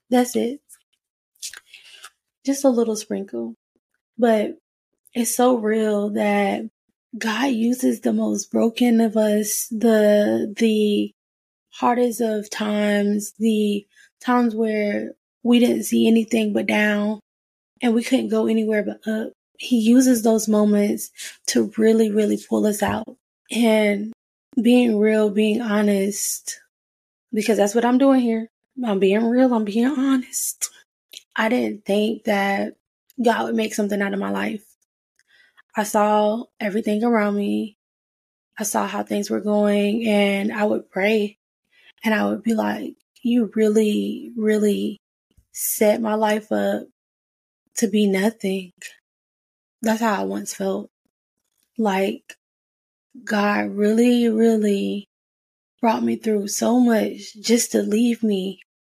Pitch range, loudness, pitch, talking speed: 205-230 Hz, -21 LUFS, 215 Hz, 130 wpm